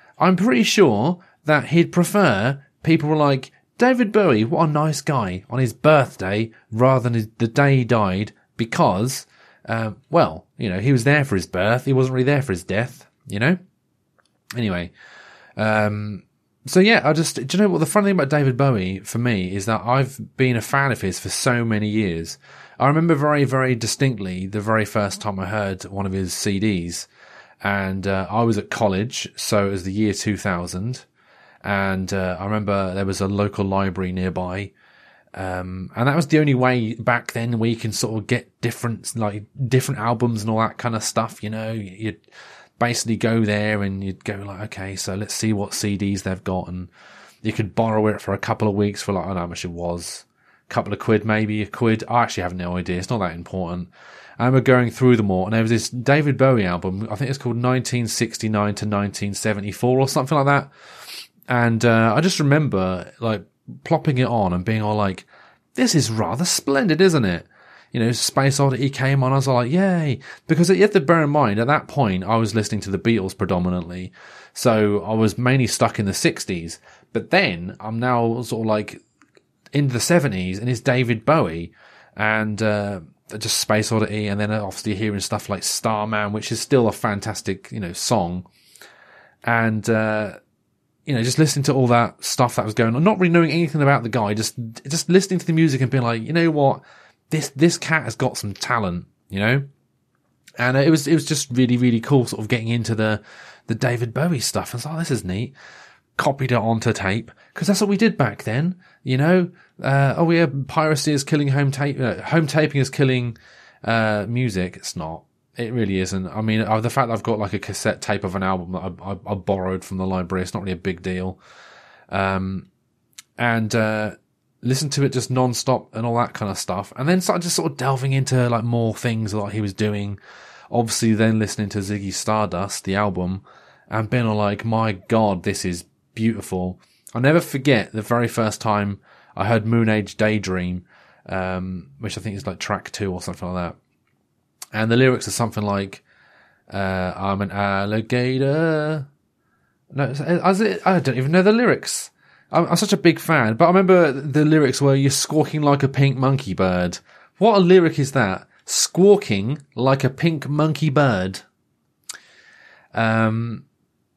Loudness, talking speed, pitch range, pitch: -20 LUFS, 200 wpm, 100-135 Hz, 115 Hz